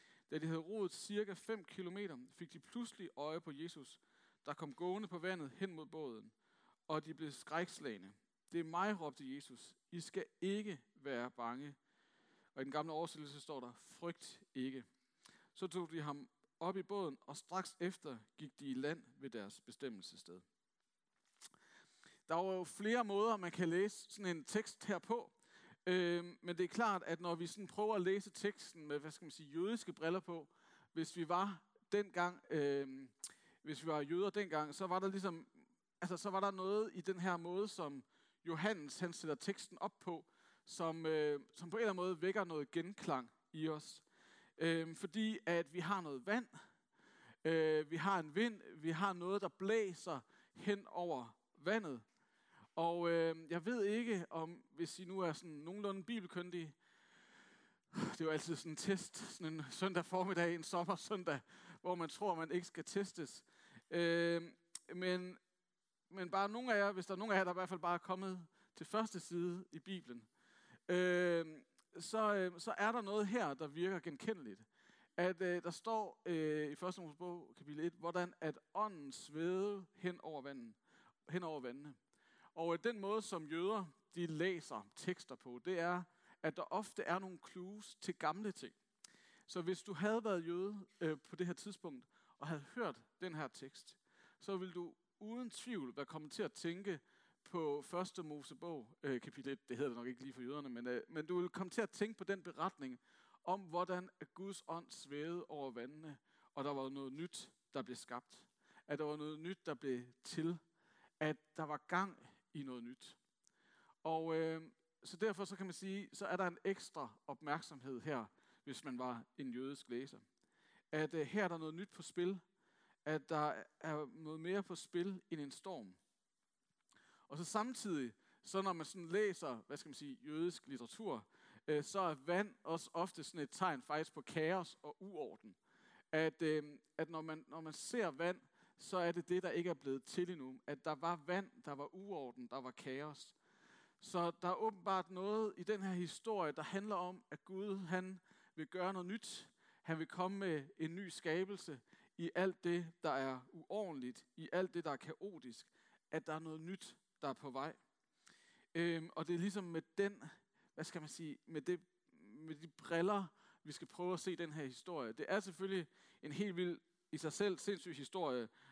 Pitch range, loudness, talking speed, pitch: 155-190 Hz, -44 LUFS, 190 wpm, 175 Hz